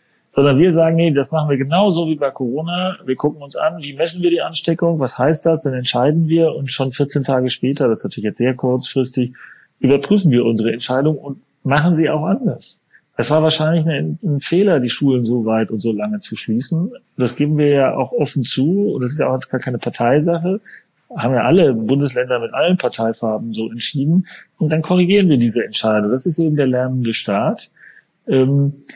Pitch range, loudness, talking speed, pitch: 125-165 Hz, -17 LUFS, 195 wpm, 140 Hz